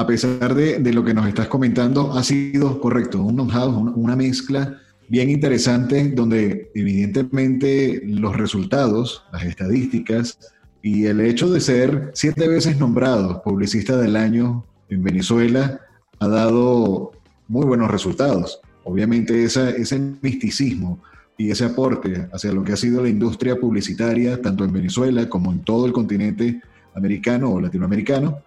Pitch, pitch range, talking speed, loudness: 120 Hz, 105-130 Hz, 145 wpm, -19 LUFS